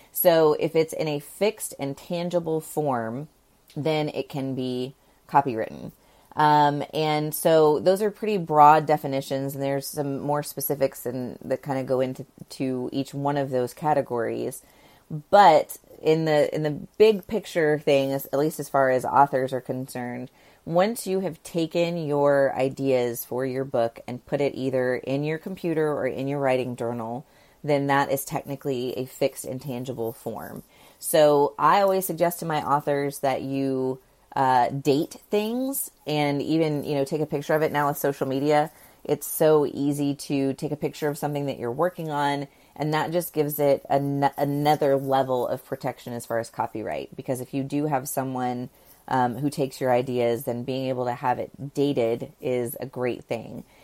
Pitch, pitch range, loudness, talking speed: 140 Hz, 130-150 Hz, -25 LUFS, 175 wpm